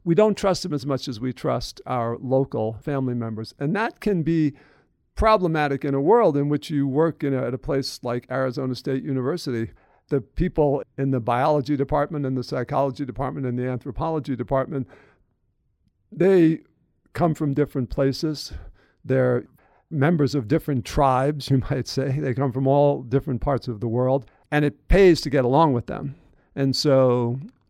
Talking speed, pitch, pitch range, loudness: 175 wpm, 140 Hz, 130-150 Hz, -23 LUFS